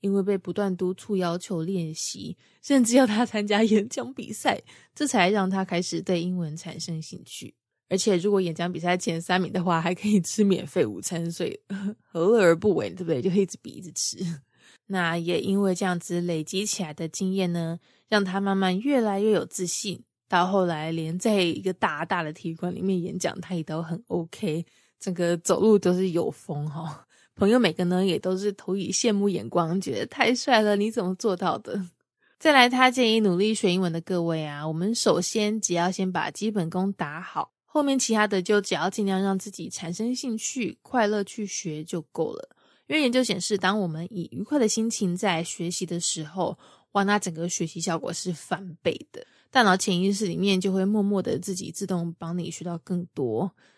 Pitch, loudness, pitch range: 190 Hz, -25 LUFS, 175-210 Hz